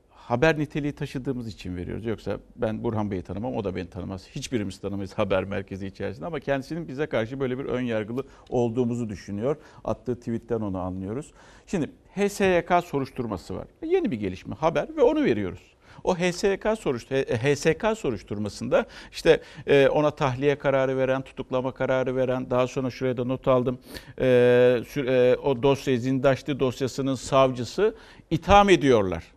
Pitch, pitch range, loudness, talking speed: 130 Hz, 115-145 Hz, -25 LUFS, 145 wpm